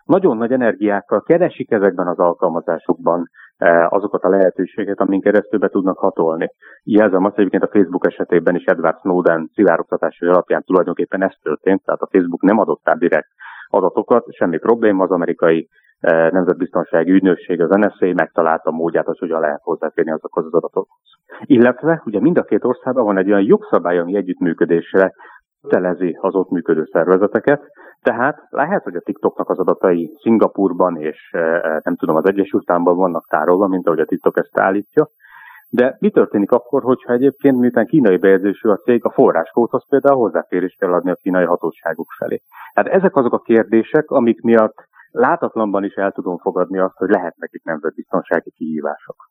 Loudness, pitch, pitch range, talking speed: -16 LUFS, 100 Hz, 90-120 Hz, 165 wpm